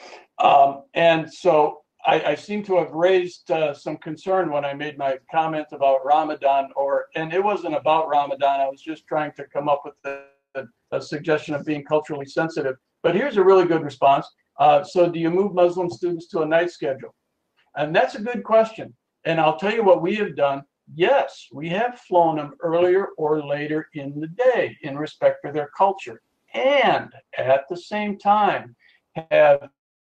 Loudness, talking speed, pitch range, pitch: -21 LUFS, 180 wpm, 145-185 Hz, 160 Hz